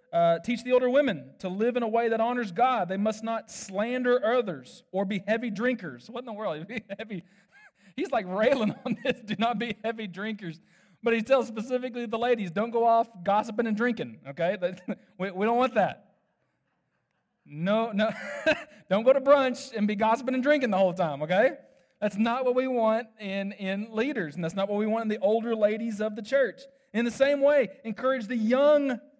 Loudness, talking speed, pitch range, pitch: -27 LUFS, 205 wpm, 200-250 Hz, 225 Hz